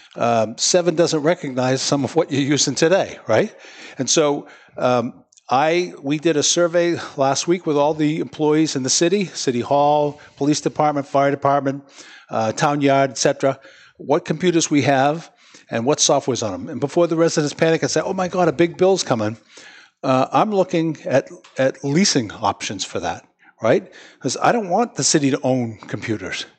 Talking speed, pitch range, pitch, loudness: 180 wpm, 135-165 Hz, 145 Hz, -19 LUFS